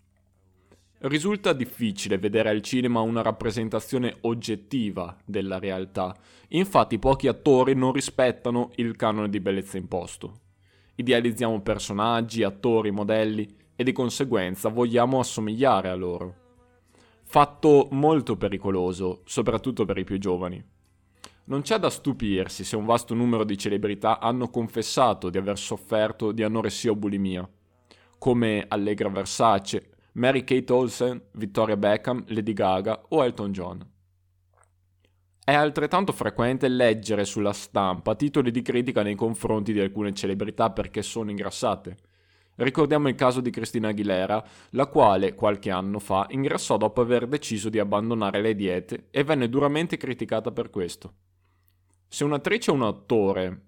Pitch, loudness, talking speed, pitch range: 110 Hz, -25 LUFS, 130 wpm, 95-120 Hz